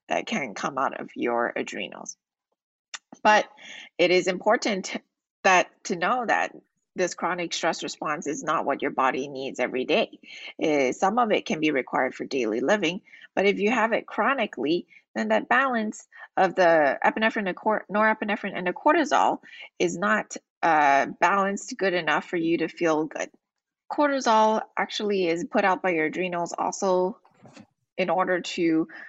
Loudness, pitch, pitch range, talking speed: -25 LUFS, 195 Hz, 175-220 Hz, 160 wpm